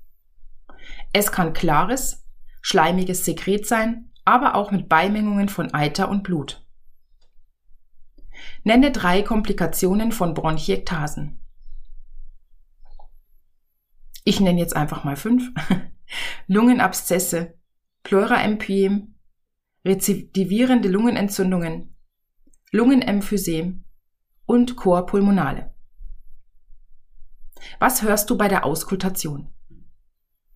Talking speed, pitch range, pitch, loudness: 75 wpm, 150-210 Hz, 190 Hz, -20 LUFS